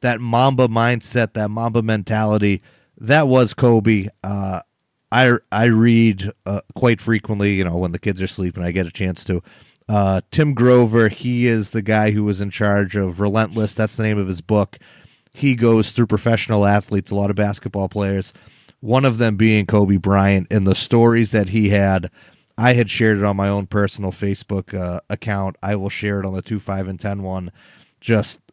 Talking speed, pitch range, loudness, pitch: 195 wpm, 100-115 Hz, -18 LUFS, 105 Hz